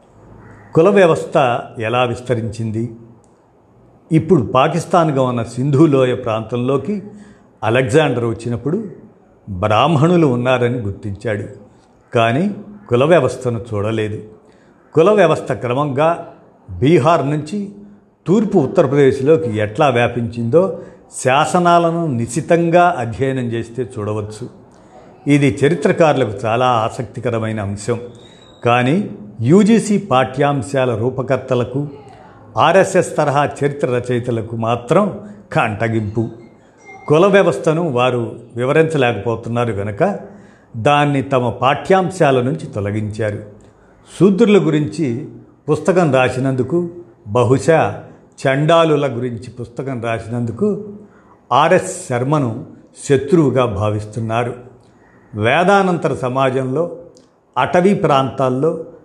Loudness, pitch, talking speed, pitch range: -16 LUFS, 130 Hz, 75 wpm, 115-160 Hz